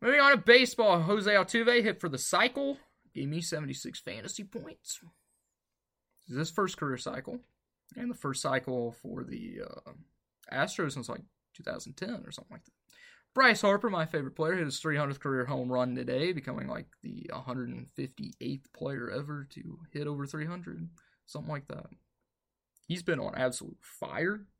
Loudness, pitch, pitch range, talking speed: -31 LUFS, 160 Hz, 135-210 Hz, 160 wpm